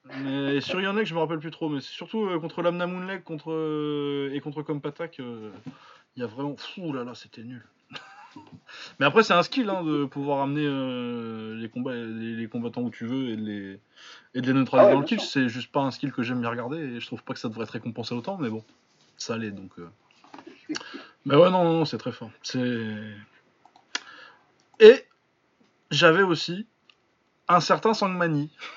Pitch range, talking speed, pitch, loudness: 120-170 Hz, 205 wpm, 140 Hz, -25 LUFS